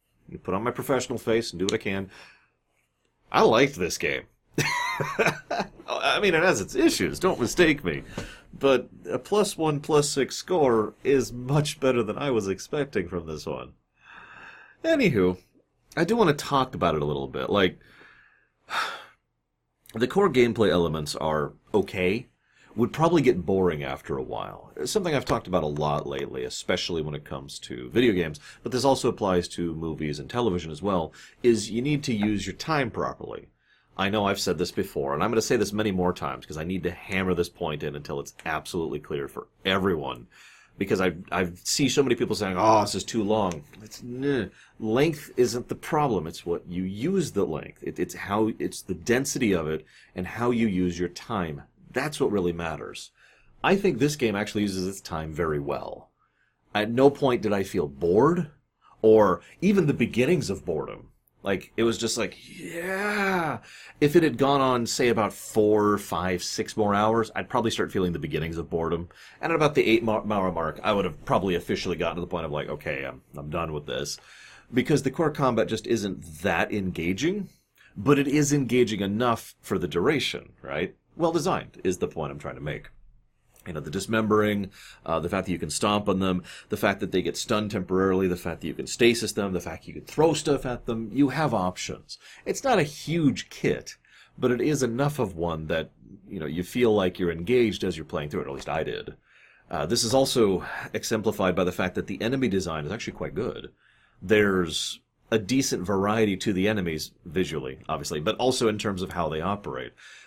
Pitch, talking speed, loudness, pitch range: 105 Hz, 205 wpm, -26 LUFS, 90-125 Hz